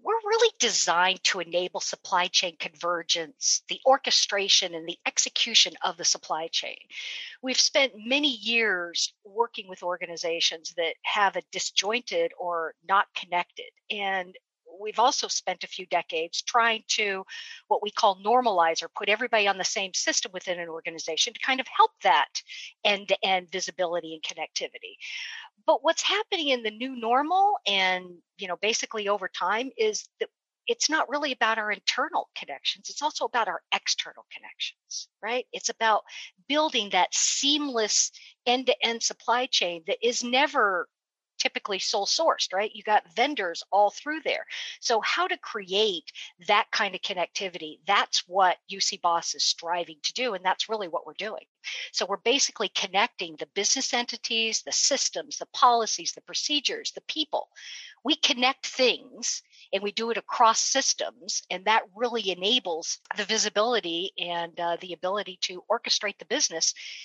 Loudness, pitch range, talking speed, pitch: -26 LUFS, 180-265 Hz, 155 wpm, 215 Hz